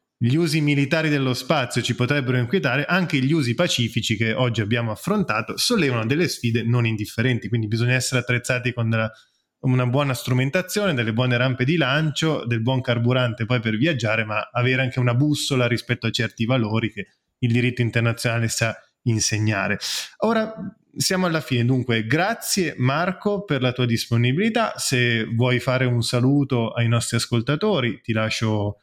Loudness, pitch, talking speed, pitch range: -21 LUFS, 125 Hz, 160 wpm, 115-145 Hz